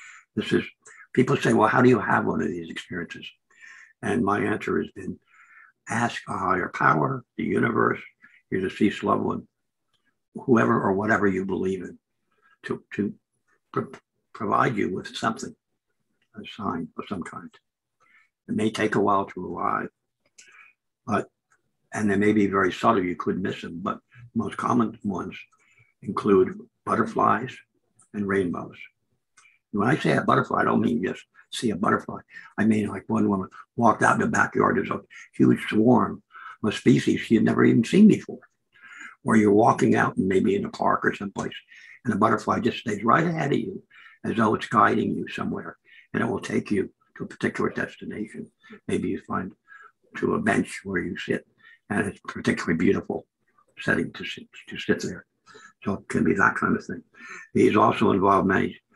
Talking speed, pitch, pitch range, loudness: 175 wpm, 110 Hz, 100-130 Hz, -24 LUFS